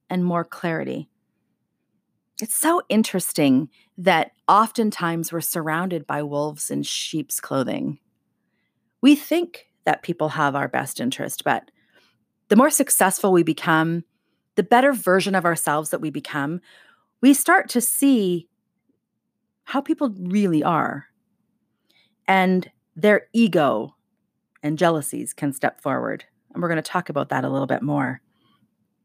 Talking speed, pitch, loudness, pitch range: 130 wpm, 185 Hz, -21 LUFS, 160-230 Hz